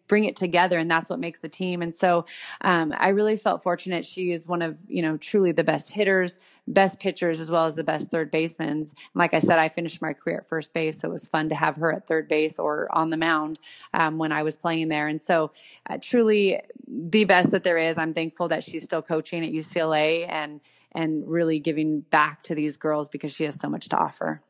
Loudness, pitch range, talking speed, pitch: -24 LUFS, 155-175 Hz, 240 wpm, 165 Hz